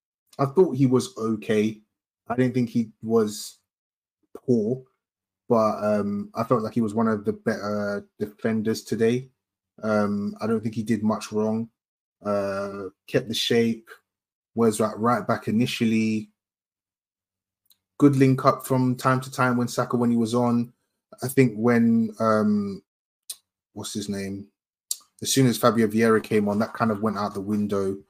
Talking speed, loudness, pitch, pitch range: 160 wpm, -24 LUFS, 110 Hz, 105-120 Hz